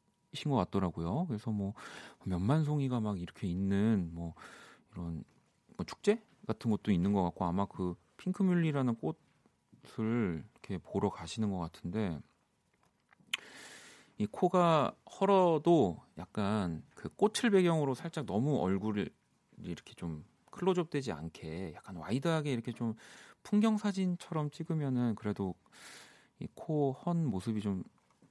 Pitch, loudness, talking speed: 115 Hz, -34 LUFS, 265 characters per minute